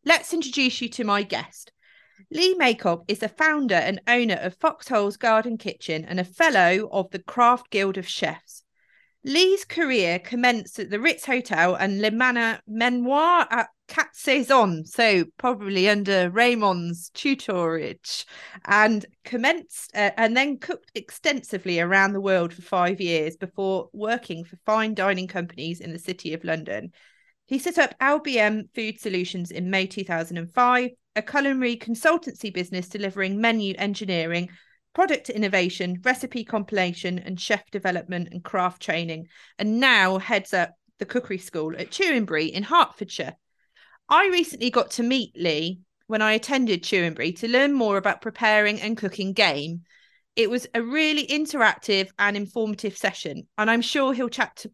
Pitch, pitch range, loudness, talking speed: 210 Hz, 185-250 Hz, -23 LUFS, 150 wpm